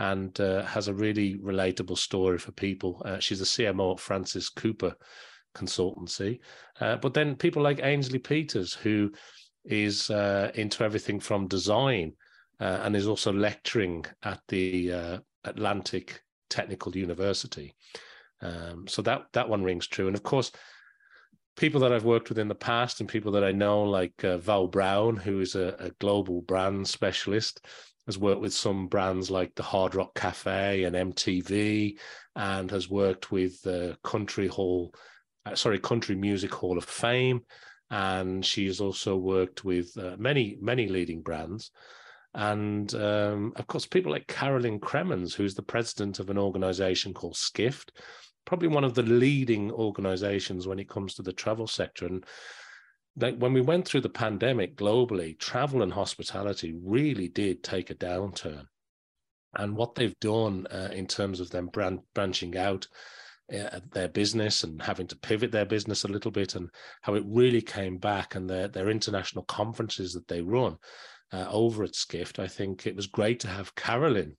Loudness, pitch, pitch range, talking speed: -29 LUFS, 100 Hz, 95-110 Hz, 170 wpm